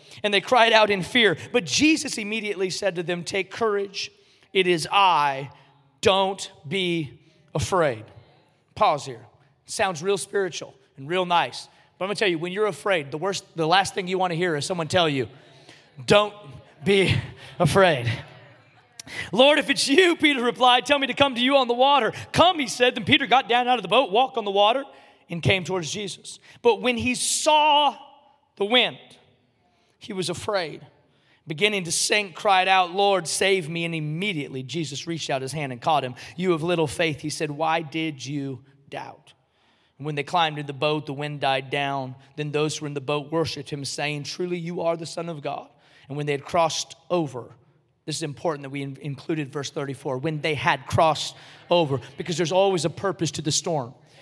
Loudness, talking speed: -23 LUFS, 200 wpm